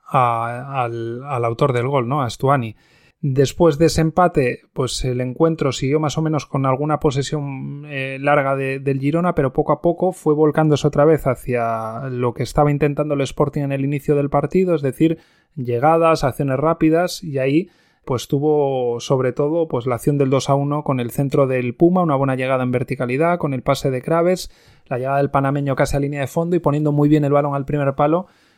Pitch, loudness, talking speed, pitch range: 145 Hz, -19 LUFS, 210 wpm, 130-155 Hz